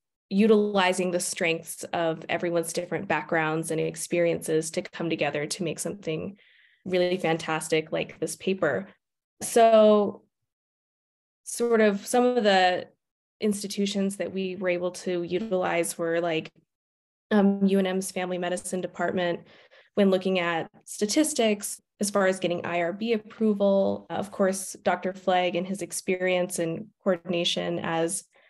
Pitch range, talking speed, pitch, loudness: 170-200 Hz, 125 wpm, 180 Hz, -26 LUFS